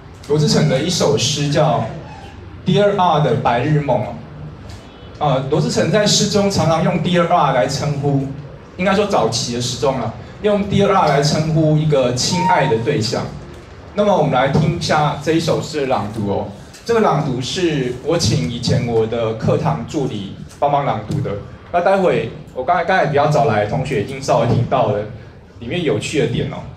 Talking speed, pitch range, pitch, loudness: 285 characters per minute, 120-170 Hz, 145 Hz, -17 LUFS